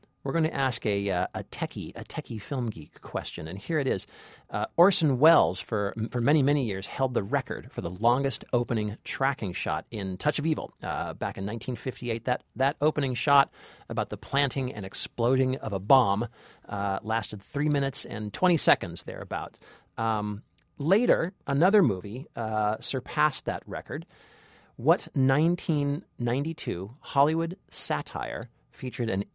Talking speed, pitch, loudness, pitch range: 155 wpm, 125 Hz, -28 LUFS, 105-145 Hz